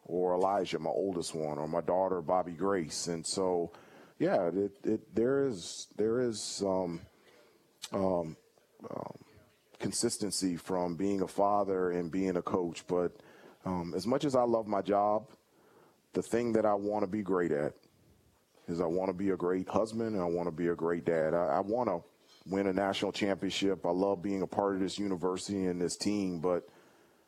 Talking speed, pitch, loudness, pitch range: 185 wpm, 95 Hz, -33 LUFS, 90-100 Hz